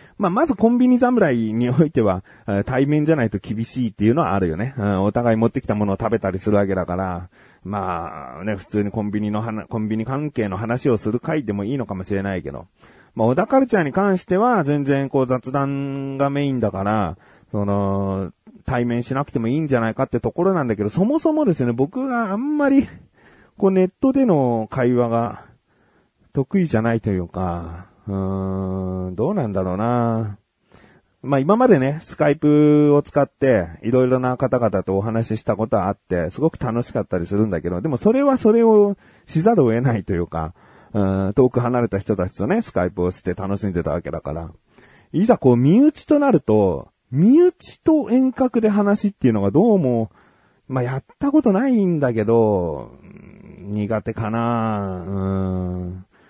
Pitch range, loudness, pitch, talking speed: 100-150 Hz, -20 LUFS, 115 Hz, 360 characters per minute